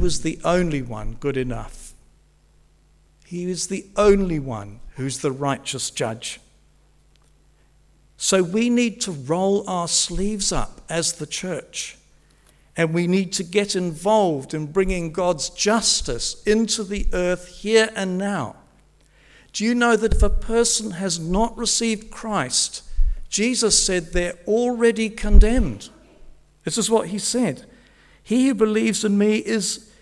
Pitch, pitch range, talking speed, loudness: 190 Hz, 155-220 Hz, 140 wpm, -21 LUFS